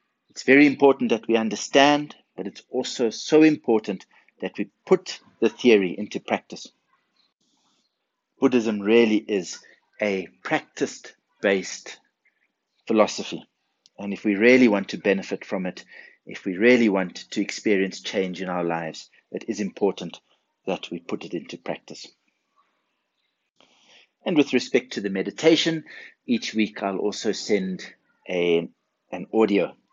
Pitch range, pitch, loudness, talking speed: 95-130 Hz, 110 Hz, -23 LUFS, 135 wpm